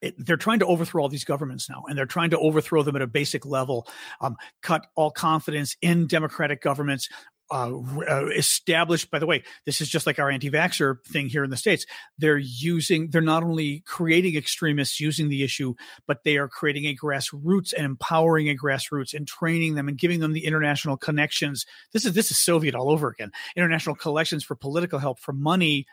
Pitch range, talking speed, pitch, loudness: 140-165 Hz, 205 wpm, 150 Hz, -24 LUFS